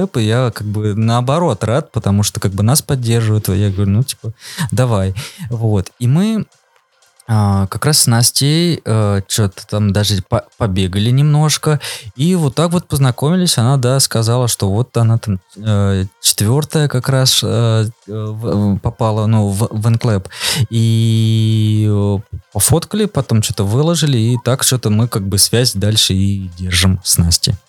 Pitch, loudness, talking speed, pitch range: 115 Hz, -14 LUFS, 155 wpm, 105-130 Hz